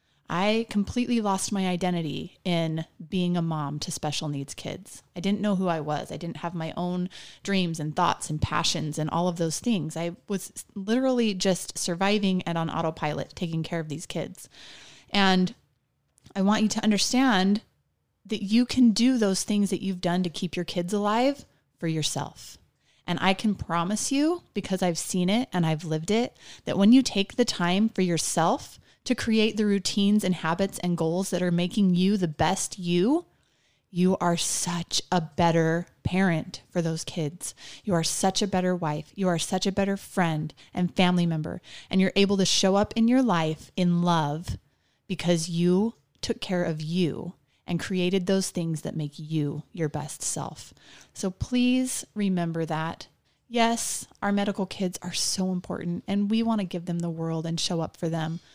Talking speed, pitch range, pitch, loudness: 185 wpm, 165-200 Hz, 180 Hz, -26 LUFS